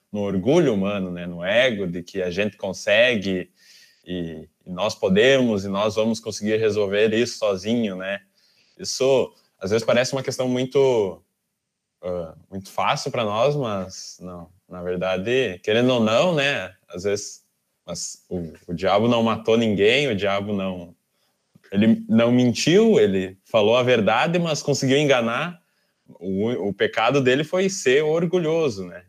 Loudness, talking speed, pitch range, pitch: -21 LUFS, 150 wpm, 95-135 Hz, 110 Hz